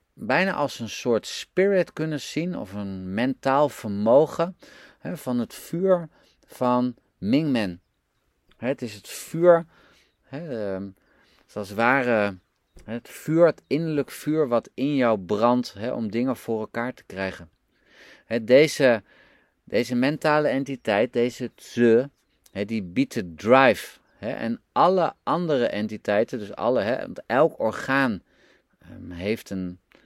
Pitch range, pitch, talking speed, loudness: 105-145 Hz, 120 Hz, 120 wpm, -24 LUFS